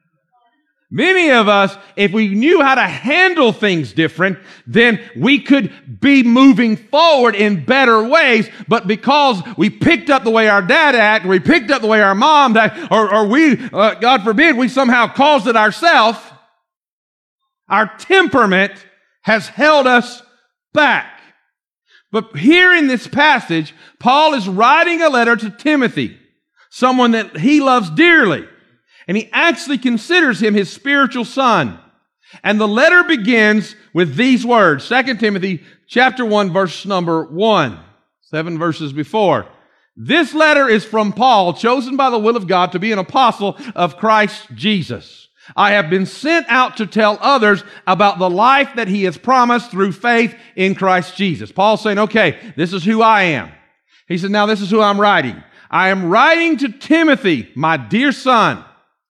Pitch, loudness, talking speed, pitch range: 220 Hz, -13 LUFS, 160 wpm, 195-270 Hz